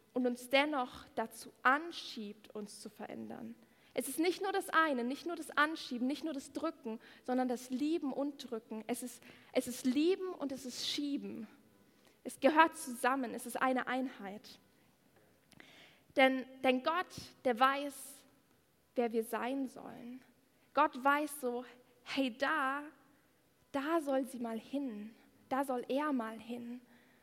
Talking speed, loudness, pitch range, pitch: 150 wpm, -36 LUFS, 245-285 Hz, 260 Hz